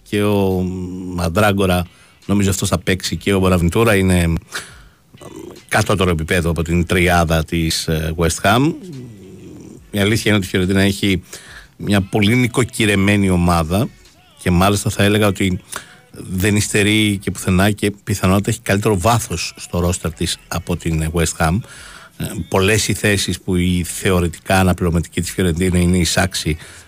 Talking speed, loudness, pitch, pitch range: 145 wpm, -17 LUFS, 95 Hz, 90-105 Hz